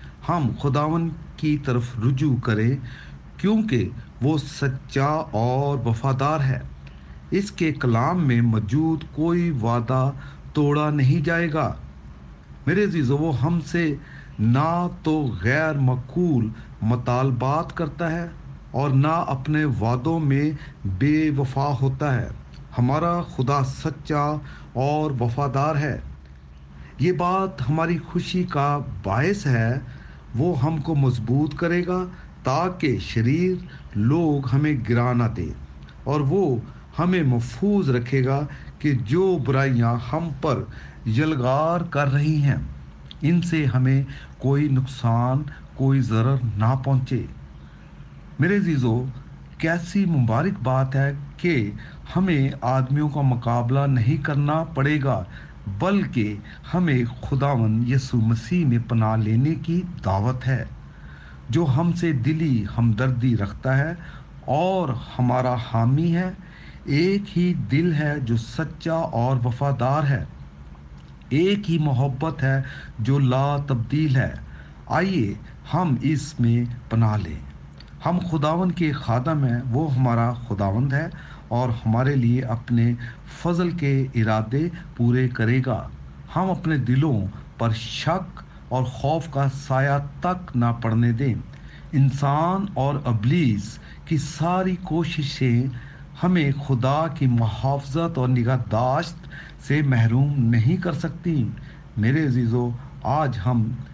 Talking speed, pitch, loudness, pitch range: 120 wpm, 135 Hz, -23 LUFS, 120-155 Hz